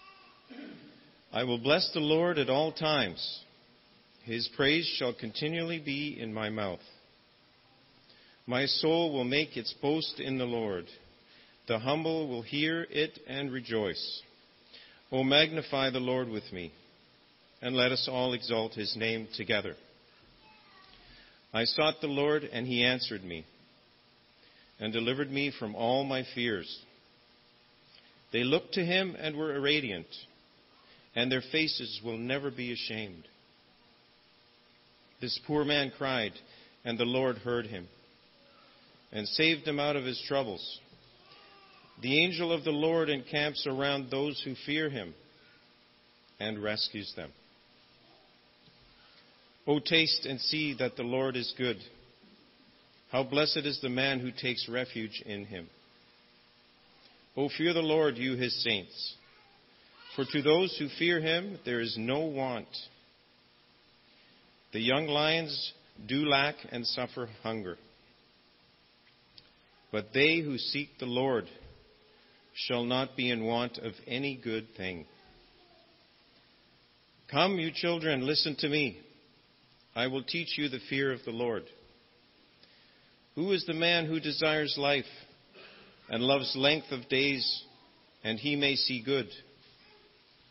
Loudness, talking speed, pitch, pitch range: -31 LUFS, 130 wpm, 125 Hz, 105-145 Hz